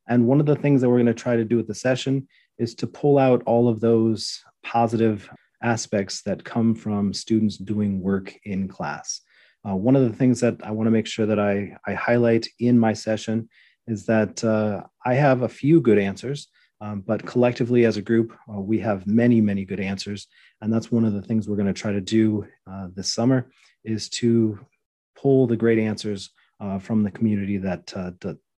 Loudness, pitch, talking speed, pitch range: -22 LUFS, 110 Hz, 210 wpm, 105-120 Hz